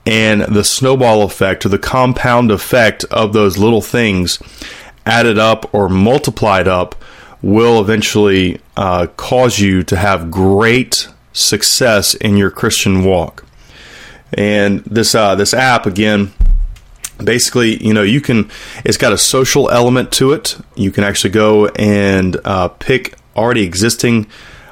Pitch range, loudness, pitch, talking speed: 95-115 Hz, -12 LUFS, 105 Hz, 140 wpm